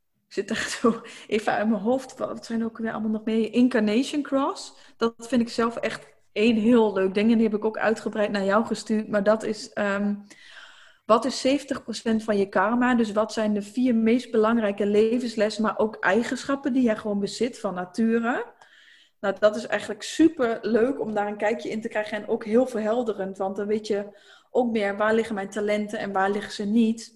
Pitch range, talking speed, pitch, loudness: 210-235 Hz, 210 wpm, 220 Hz, -25 LUFS